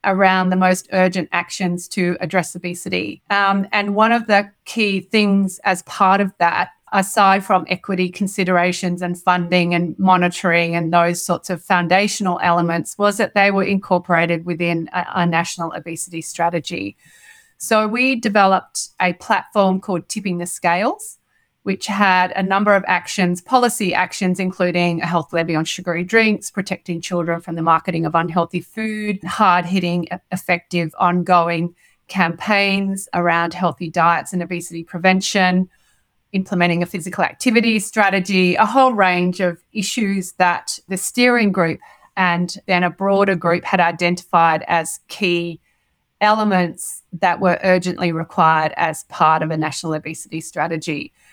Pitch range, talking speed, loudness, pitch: 170-195 Hz, 140 wpm, -18 LUFS, 180 Hz